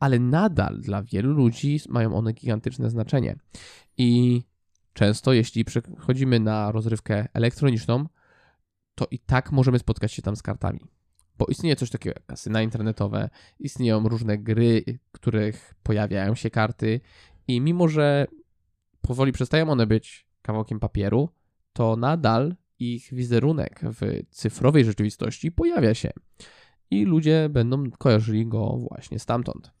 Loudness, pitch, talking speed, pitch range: -24 LUFS, 115 Hz, 130 wpm, 110-130 Hz